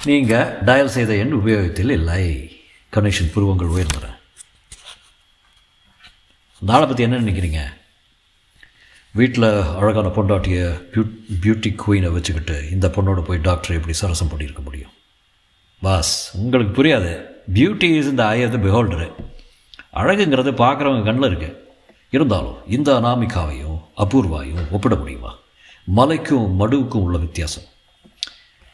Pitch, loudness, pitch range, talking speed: 95 Hz, -18 LUFS, 85-115 Hz, 105 wpm